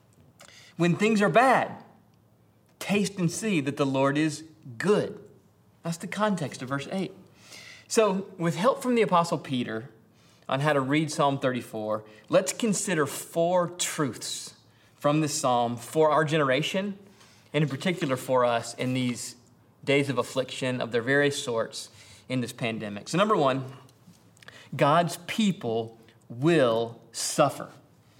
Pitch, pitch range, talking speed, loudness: 145 Hz, 125-170 Hz, 140 wpm, -26 LUFS